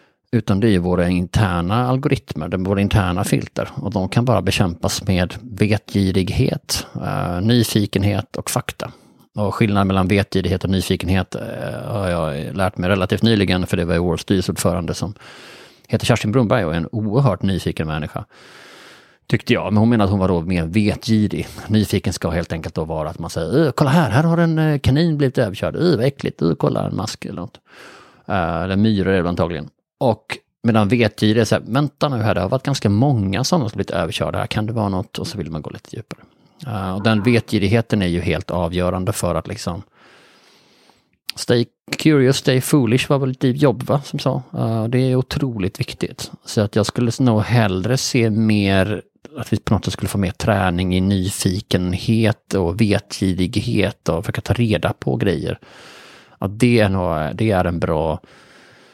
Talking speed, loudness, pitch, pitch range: 190 wpm, -19 LUFS, 105 Hz, 95-120 Hz